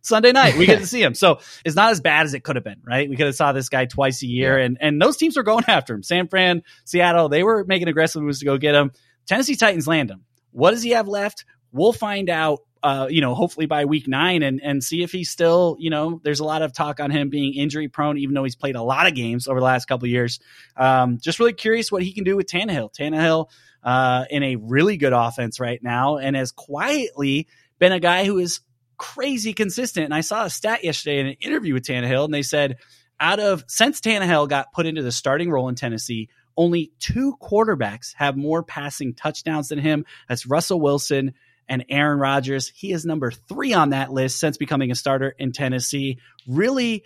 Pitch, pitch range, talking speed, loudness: 150 Hz, 130-175 Hz, 230 wpm, -20 LUFS